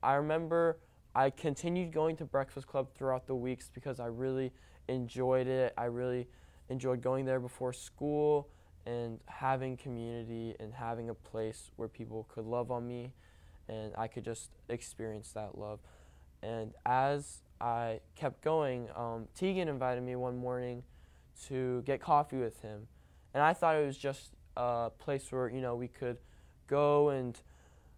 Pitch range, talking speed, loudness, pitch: 110-135 Hz, 160 wpm, -36 LUFS, 125 Hz